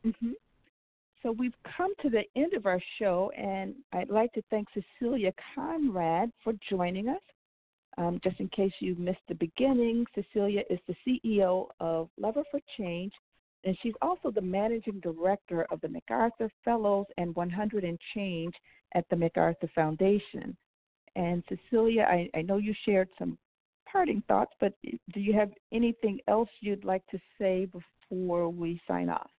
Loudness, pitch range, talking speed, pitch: -31 LUFS, 180-230 Hz, 160 wpm, 200 Hz